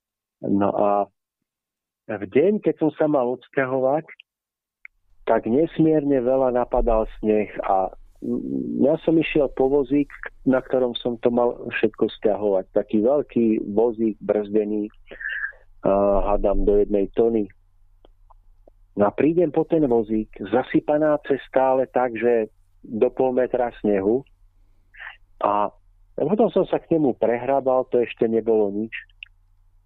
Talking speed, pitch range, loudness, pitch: 120 wpm, 100-130 Hz, -22 LUFS, 115 Hz